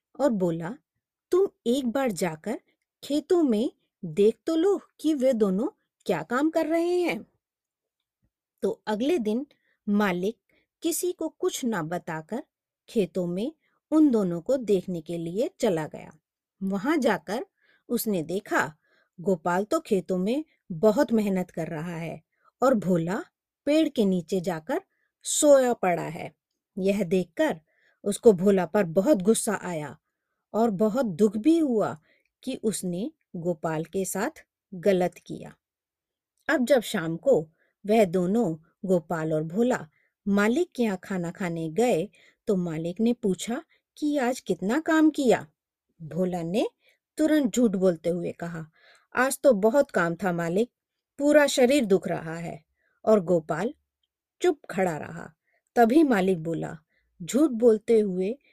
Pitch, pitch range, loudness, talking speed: 215 Hz, 185-275 Hz, -26 LUFS, 135 wpm